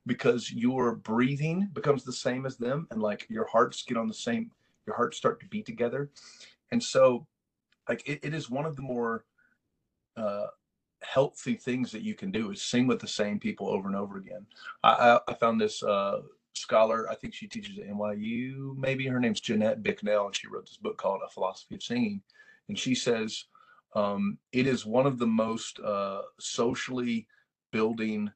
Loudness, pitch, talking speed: -30 LUFS, 125 Hz, 190 wpm